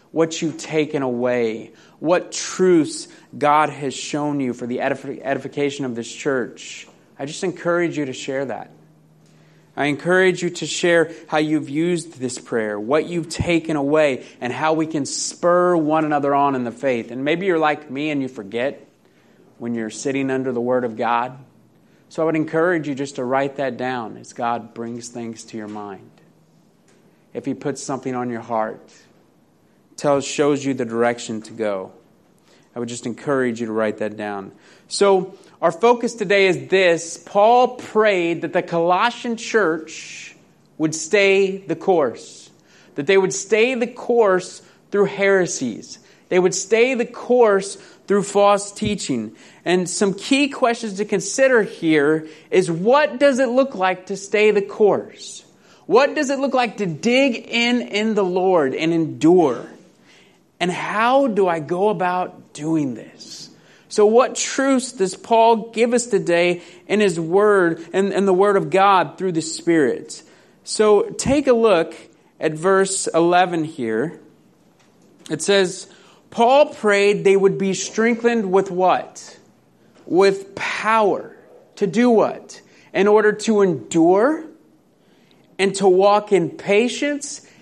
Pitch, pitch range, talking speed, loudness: 180 Hz, 145-210 Hz, 155 wpm, -19 LUFS